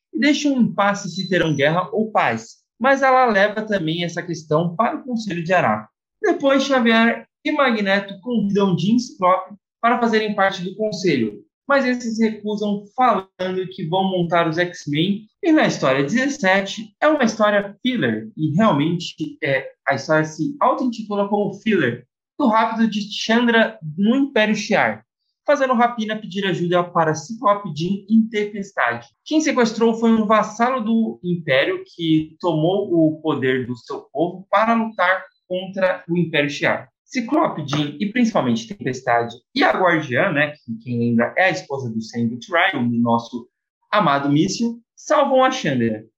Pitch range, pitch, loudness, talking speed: 160-230 Hz, 195 Hz, -19 LUFS, 150 wpm